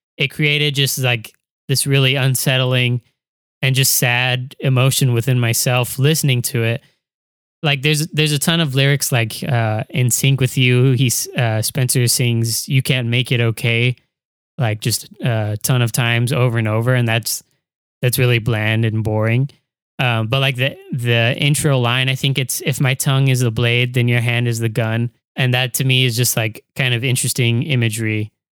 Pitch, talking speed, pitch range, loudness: 125 Hz, 185 wpm, 120-135 Hz, -17 LUFS